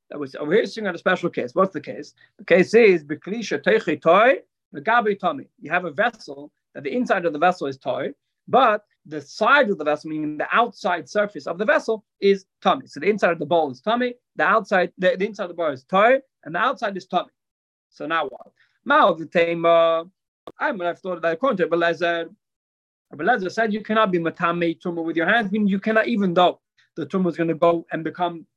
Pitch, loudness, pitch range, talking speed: 180 Hz, -21 LUFS, 165-215 Hz, 215 wpm